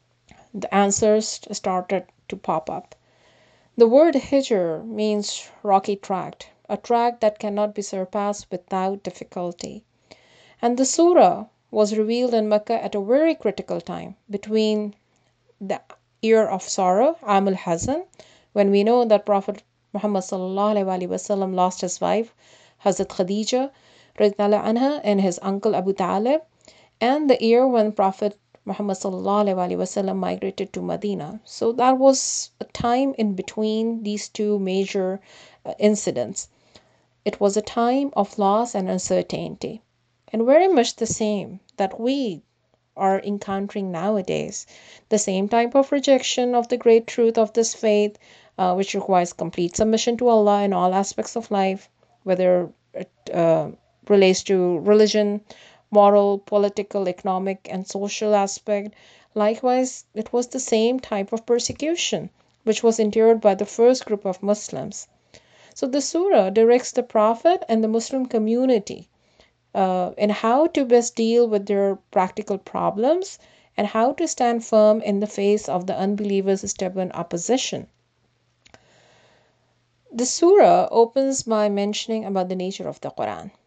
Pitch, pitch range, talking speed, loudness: 210 Hz, 195-230 Hz, 135 wpm, -21 LUFS